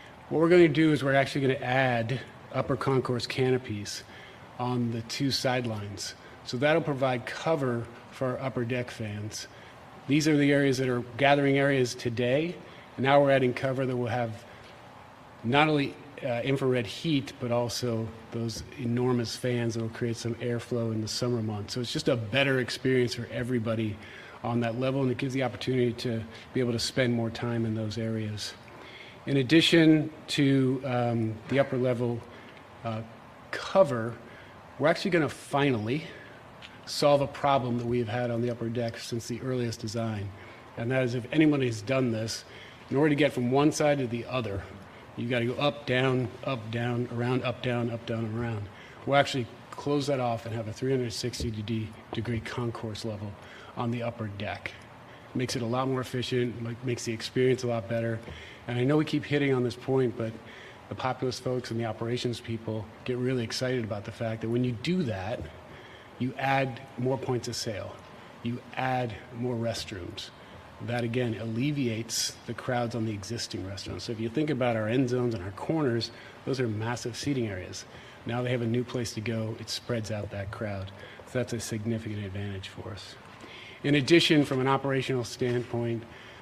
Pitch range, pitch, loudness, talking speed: 115-130 Hz, 120 Hz, -29 LUFS, 185 wpm